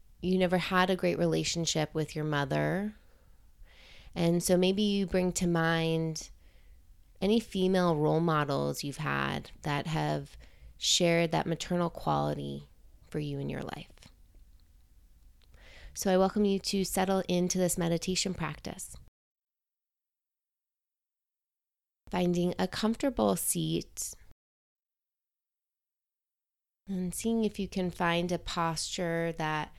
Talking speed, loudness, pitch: 115 wpm, -30 LUFS, 165 Hz